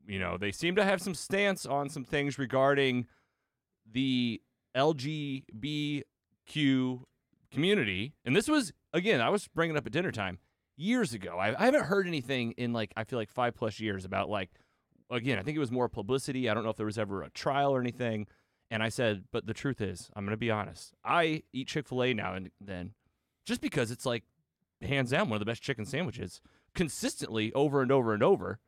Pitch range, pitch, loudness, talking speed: 105-145 Hz, 125 Hz, -31 LUFS, 205 wpm